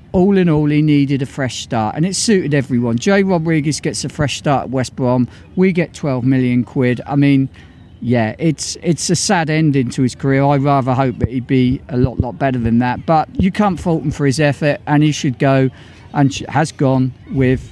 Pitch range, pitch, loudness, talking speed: 125-155 Hz, 140 Hz, -16 LUFS, 220 wpm